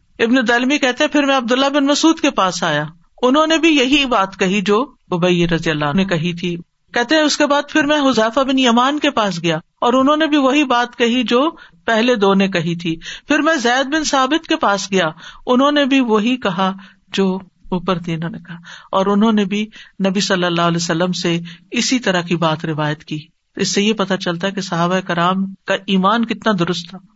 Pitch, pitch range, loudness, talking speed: 205 Hz, 180-265 Hz, -16 LUFS, 215 wpm